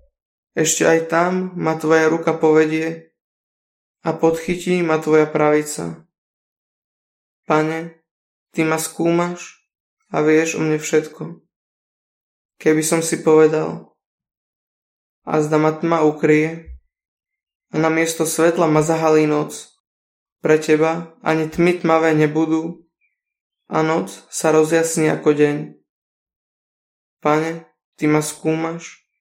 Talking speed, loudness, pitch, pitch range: 110 wpm, -18 LUFS, 160 Hz, 155-165 Hz